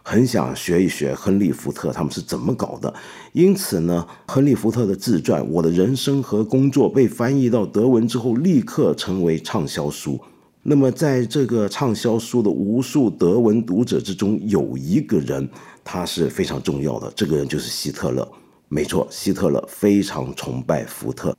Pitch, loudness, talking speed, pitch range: 115 Hz, -20 LUFS, 265 characters per minute, 95-130 Hz